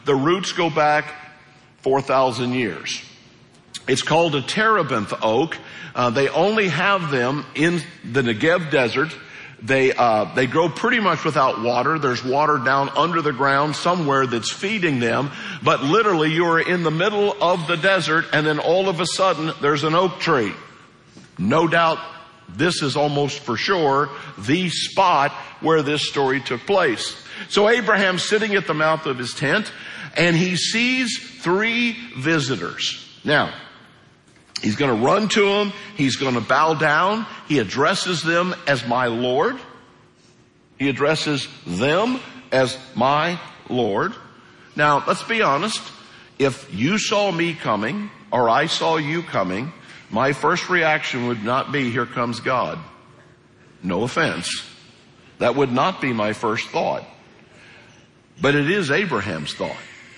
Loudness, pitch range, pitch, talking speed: -20 LUFS, 135-180 Hz, 155 Hz, 145 wpm